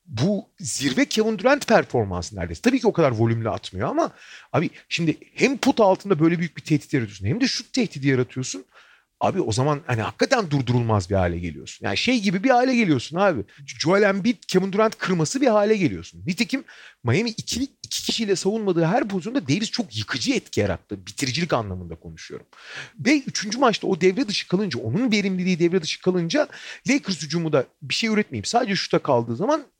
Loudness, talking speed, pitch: -22 LUFS, 180 wpm, 185 Hz